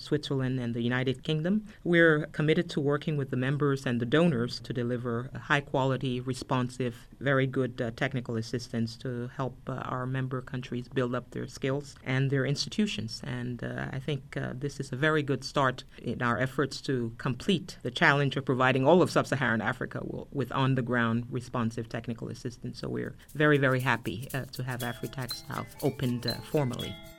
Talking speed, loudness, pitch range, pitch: 185 wpm, -30 LUFS, 120-145 Hz, 130 Hz